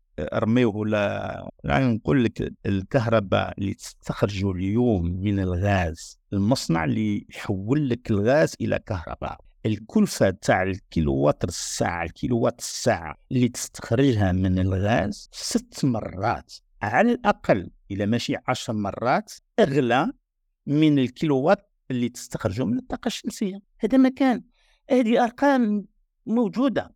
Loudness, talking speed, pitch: -24 LUFS, 110 wpm, 120 Hz